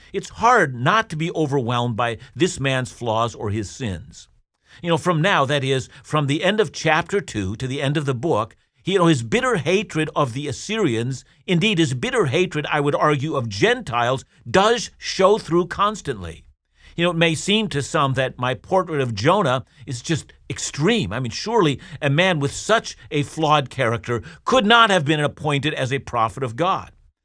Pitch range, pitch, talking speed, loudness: 125-175 Hz, 145 Hz, 190 wpm, -20 LUFS